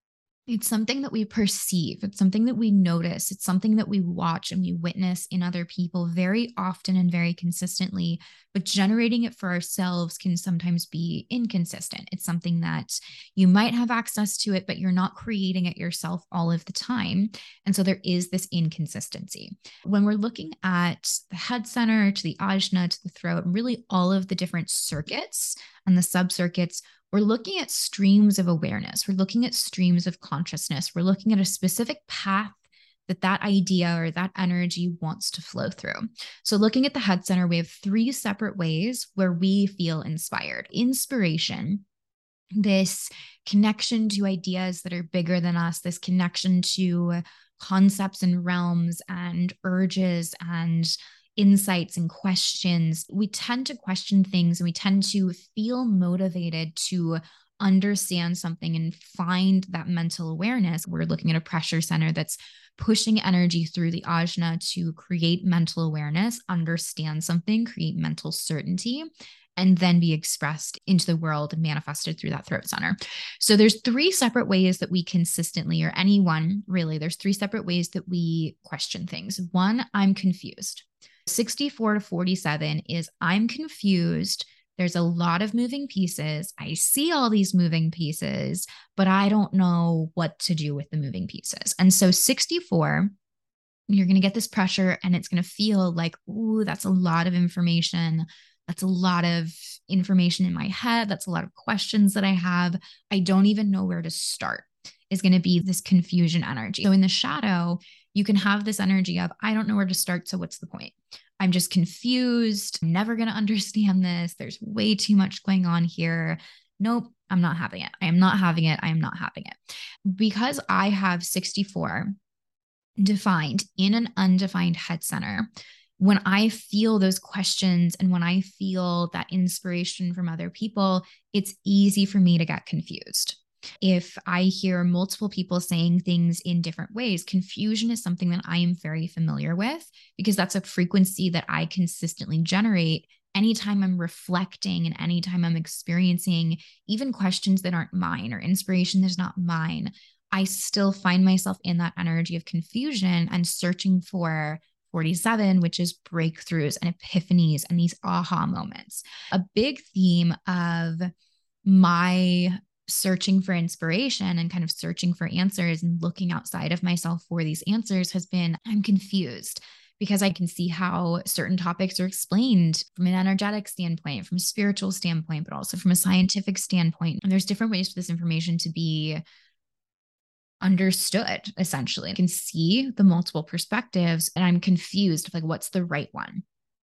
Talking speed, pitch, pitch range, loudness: 170 wpm, 185 Hz, 170-200 Hz, -25 LUFS